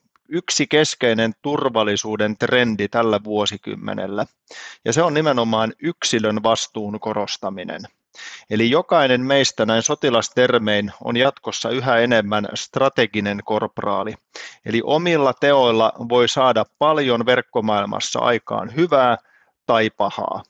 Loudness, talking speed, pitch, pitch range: -19 LUFS, 100 wpm, 115 Hz, 110-135 Hz